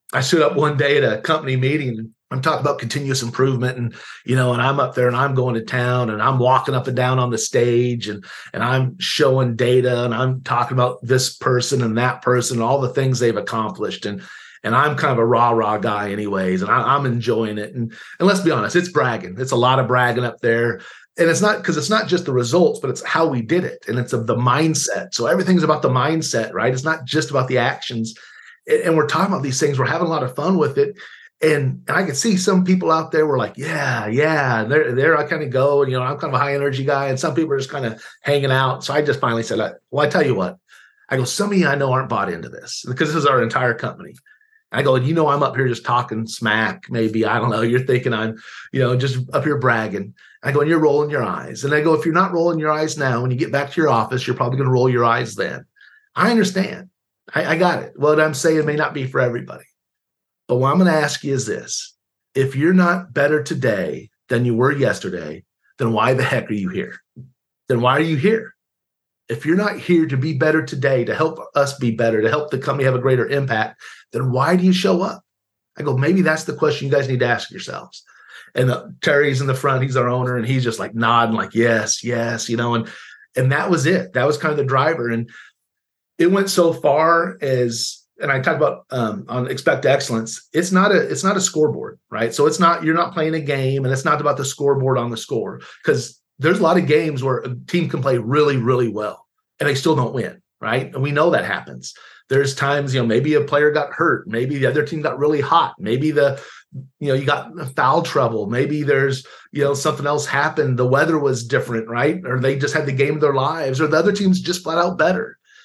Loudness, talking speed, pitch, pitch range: -19 LUFS, 250 wpm, 140 Hz, 125-155 Hz